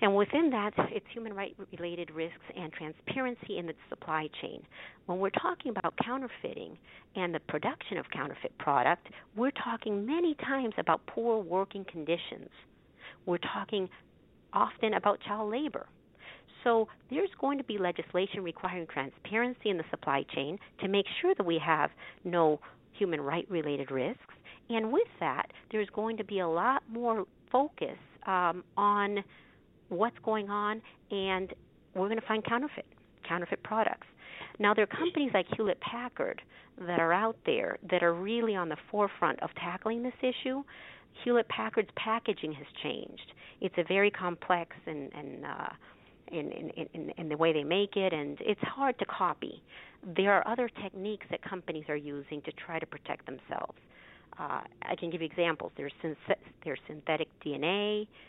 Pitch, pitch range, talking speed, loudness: 200 Hz, 170-230 Hz, 165 wpm, -33 LUFS